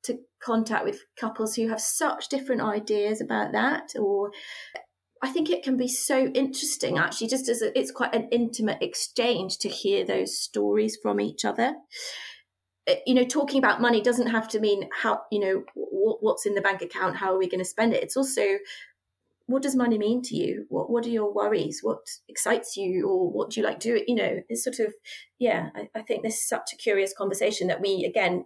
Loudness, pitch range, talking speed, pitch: -26 LUFS, 205-270 Hz, 215 wpm, 235 Hz